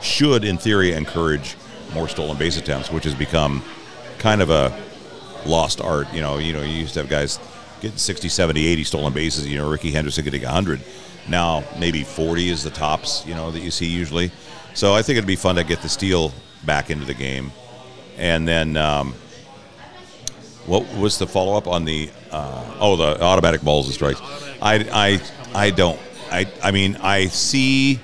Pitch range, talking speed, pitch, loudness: 75-95 Hz, 190 wpm, 80 Hz, -20 LUFS